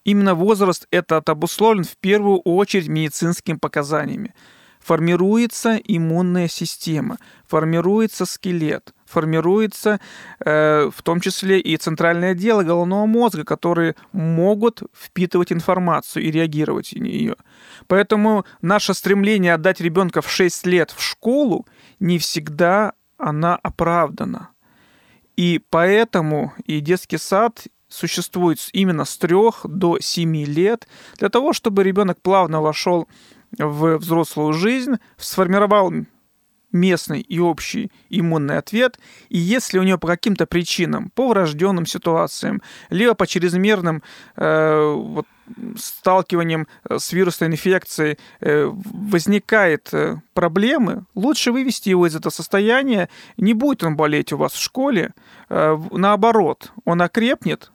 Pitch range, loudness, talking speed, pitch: 165-215 Hz, -19 LUFS, 115 wpm, 185 Hz